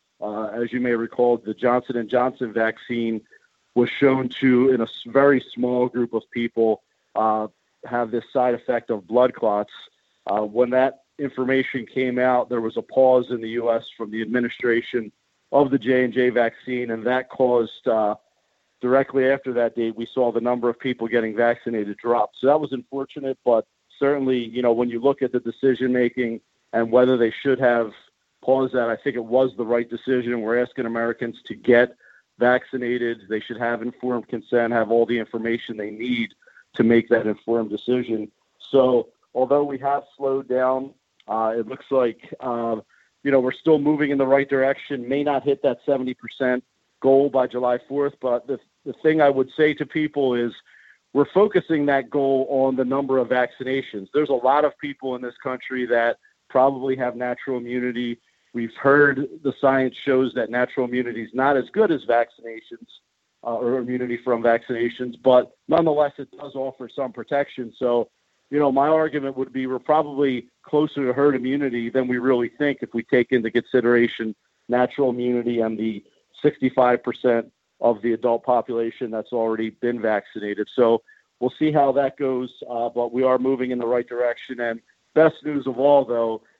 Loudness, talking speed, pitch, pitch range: -22 LUFS, 180 wpm, 125 Hz, 120-135 Hz